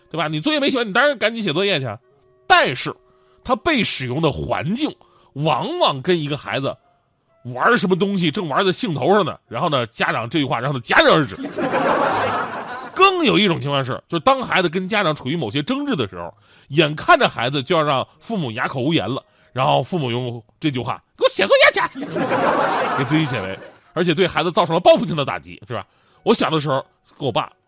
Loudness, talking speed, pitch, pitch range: -19 LUFS, 305 characters per minute, 160 Hz, 130-210 Hz